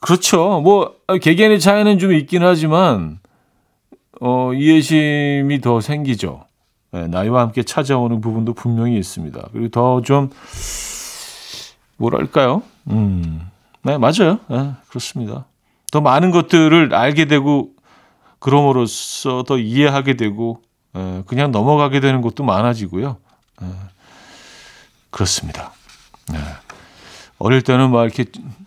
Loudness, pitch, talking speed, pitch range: -16 LUFS, 130 Hz, 250 characters per minute, 115-150 Hz